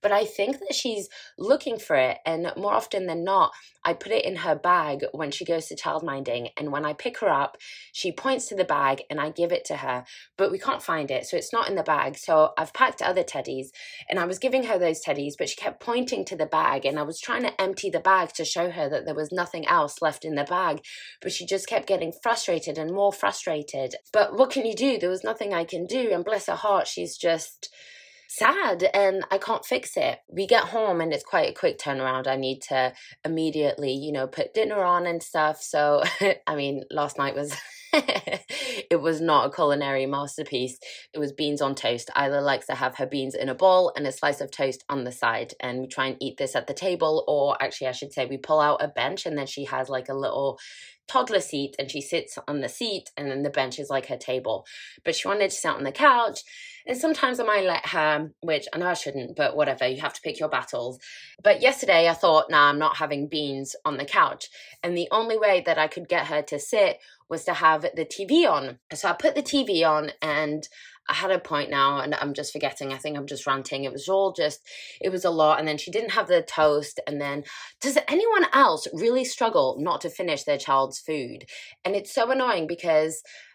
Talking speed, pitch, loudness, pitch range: 235 wpm, 160 Hz, -25 LUFS, 140-200 Hz